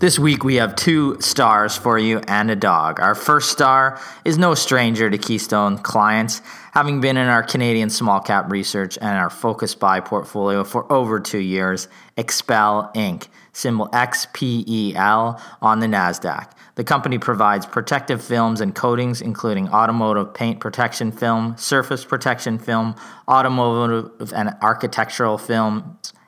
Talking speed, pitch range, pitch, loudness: 150 wpm, 105-125 Hz, 115 Hz, -18 LUFS